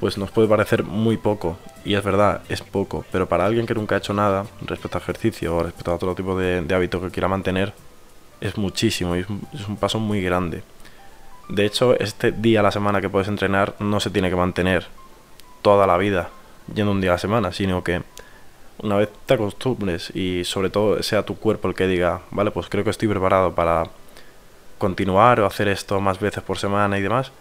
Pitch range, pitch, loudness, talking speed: 90-105 Hz, 100 Hz, -21 LUFS, 210 wpm